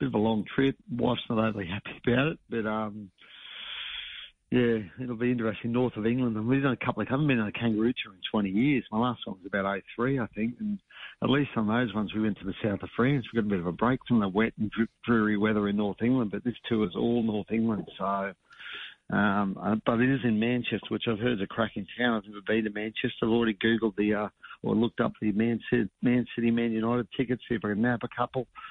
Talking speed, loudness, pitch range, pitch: 255 wpm, -29 LUFS, 105-120 Hz, 115 Hz